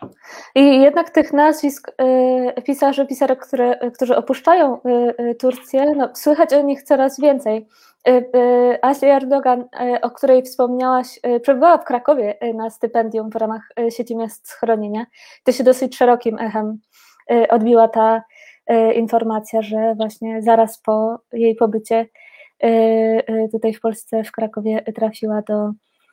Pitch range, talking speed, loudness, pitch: 225-270 Hz, 150 wpm, -17 LUFS, 245 Hz